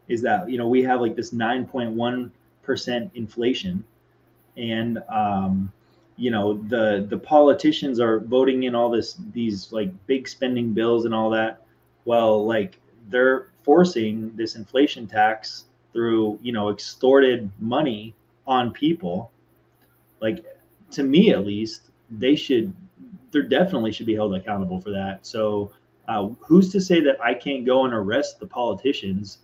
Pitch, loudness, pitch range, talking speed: 115 Hz, -22 LUFS, 110-130 Hz, 155 wpm